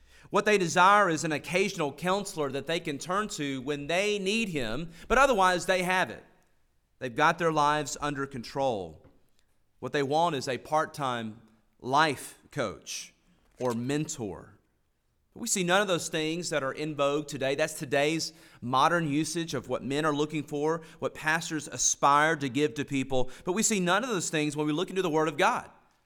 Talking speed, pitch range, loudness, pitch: 190 wpm, 140-175 Hz, -28 LUFS, 155 Hz